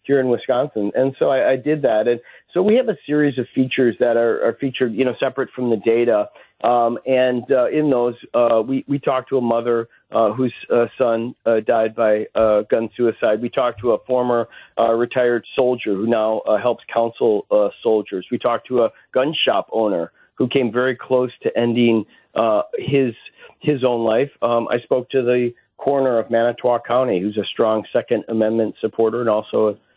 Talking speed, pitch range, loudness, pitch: 200 wpm, 115-130 Hz, -19 LUFS, 120 Hz